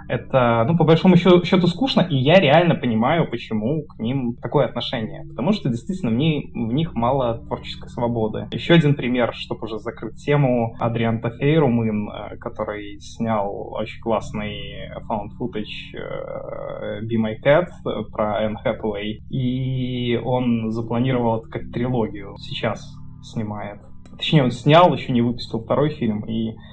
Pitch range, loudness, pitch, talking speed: 110-145 Hz, -21 LUFS, 120 Hz, 140 wpm